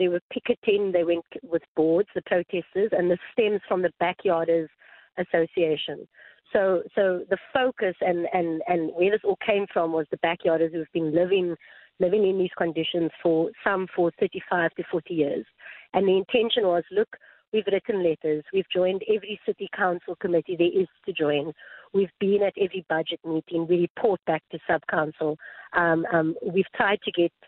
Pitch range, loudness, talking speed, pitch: 165-195 Hz, -25 LUFS, 180 wpm, 180 Hz